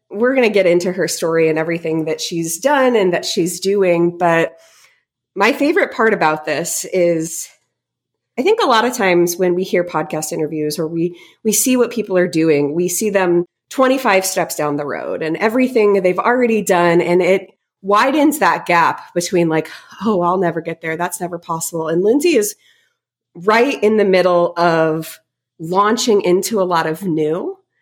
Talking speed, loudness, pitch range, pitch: 180 wpm, -16 LUFS, 165-215 Hz, 180 Hz